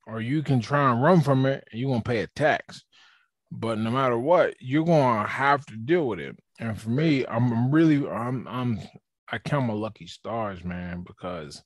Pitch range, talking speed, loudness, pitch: 110-140 Hz, 210 wpm, -25 LUFS, 120 Hz